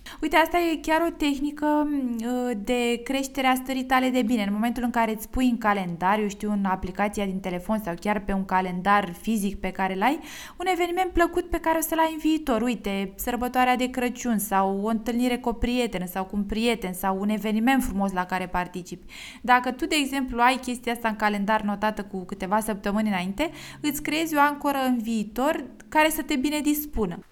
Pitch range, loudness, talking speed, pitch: 205-280 Hz, -25 LUFS, 200 wpm, 240 Hz